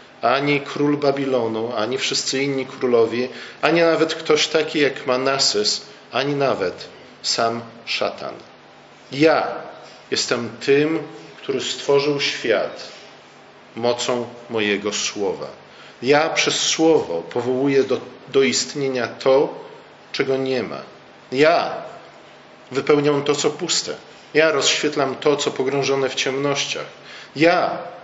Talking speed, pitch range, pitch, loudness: 105 wpm, 125-145 Hz, 135 Hz, -20 LUFS